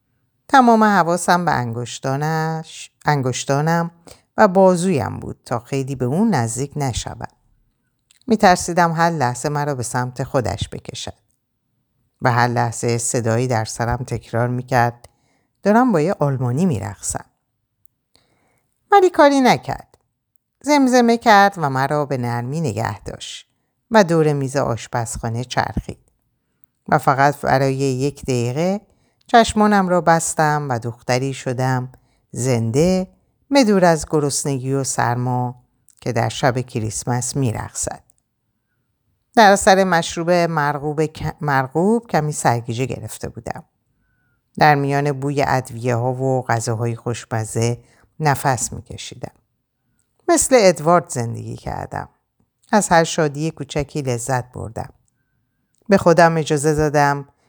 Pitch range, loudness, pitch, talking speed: 120-160 Hz, -18 LUFS, 135 Hz, 110 wpm